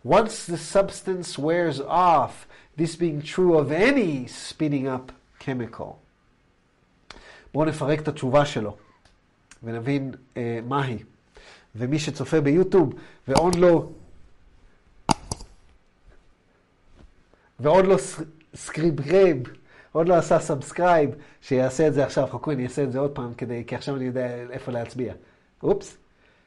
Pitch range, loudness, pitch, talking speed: 120-160 Hz, -24 LUFS, 140 Hz, 115 wpm